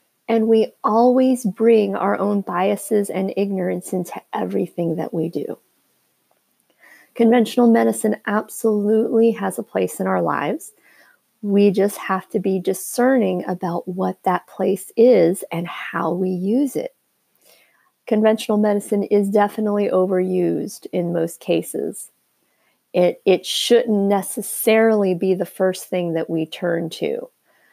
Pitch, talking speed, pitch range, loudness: 200 Hz, 130 wpm, 185-220 Hz, -19 LUFS